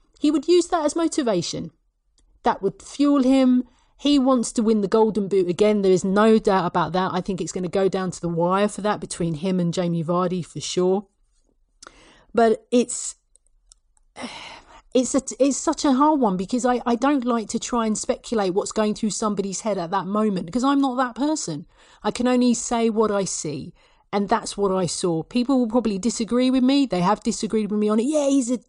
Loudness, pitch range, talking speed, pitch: -22 LUFS, 195-255 Hz, 215 wpm, 220 Hz